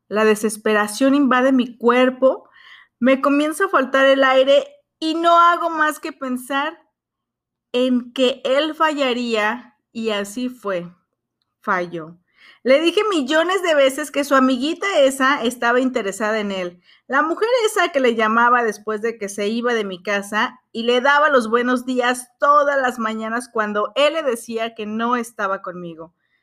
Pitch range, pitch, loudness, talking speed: 220-285 Hz, 250 Hz, -18 LUFS, 155 wpm